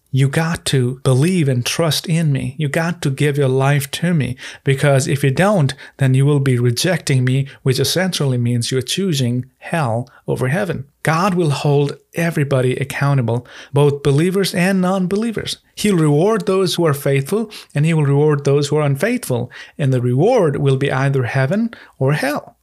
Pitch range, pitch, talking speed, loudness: 135-170 Hz, 145 Hz, 175 wpm, -17 LUFS